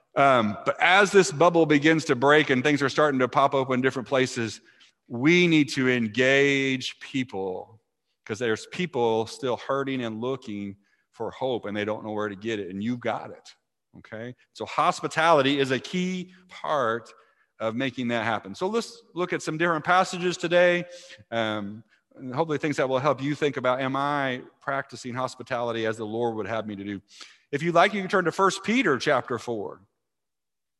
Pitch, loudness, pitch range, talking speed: 135 Hz, -24 LUFS, 115-165 Hz, 185 wpm